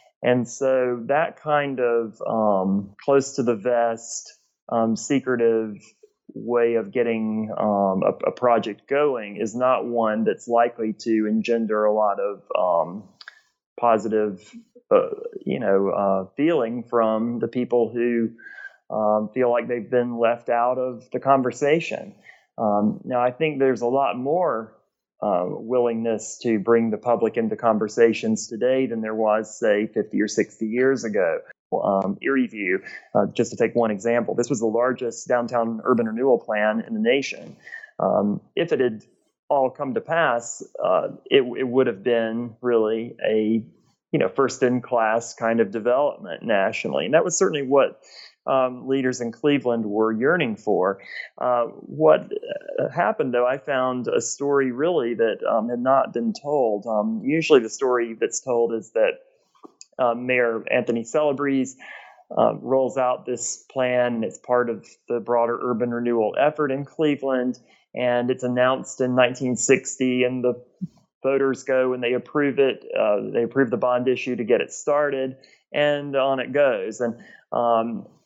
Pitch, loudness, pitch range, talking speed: 125 Hz, -22 LUFS, 115-135 Hz, 160 wpm